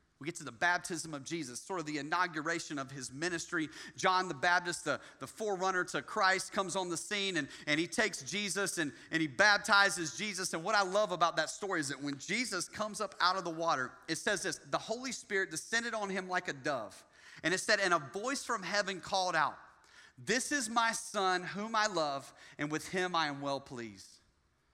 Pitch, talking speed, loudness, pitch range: 180 Hz, 215 wpm, -34 LUFS, 155-205 Hz